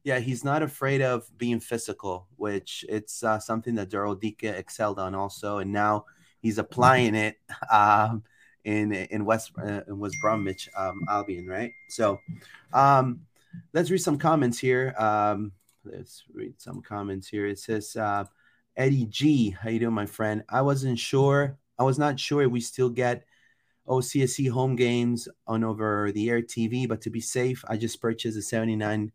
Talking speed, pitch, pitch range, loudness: 170 wpm, 115 Hz, 105-130 Hz, -26 LUFS